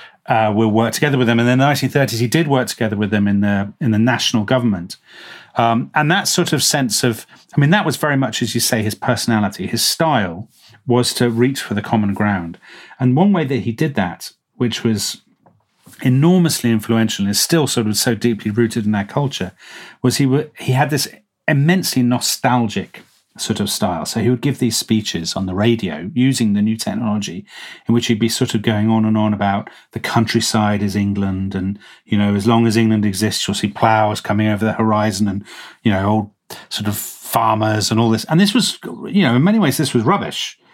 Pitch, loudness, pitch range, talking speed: 115 Hz, -17 LUFS, 105-130 Hz, 215 wpm